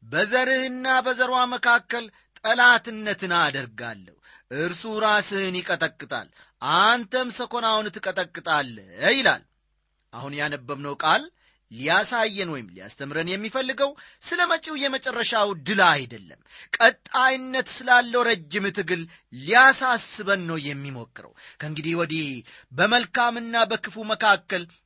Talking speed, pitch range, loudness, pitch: 85 wpm, 160-245 Hz, -22 LUFS, 210 Hz